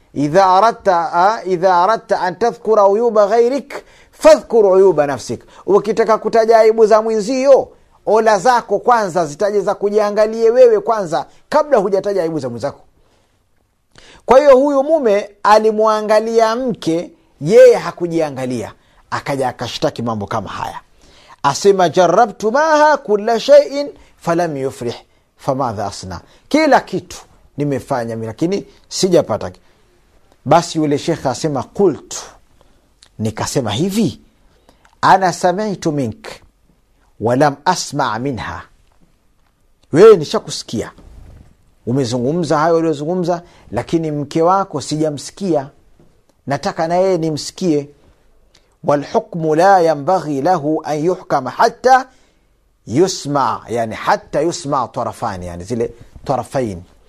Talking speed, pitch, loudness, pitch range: 85 wpm, 170 Hz, -15 LUFS, 135-215 Hz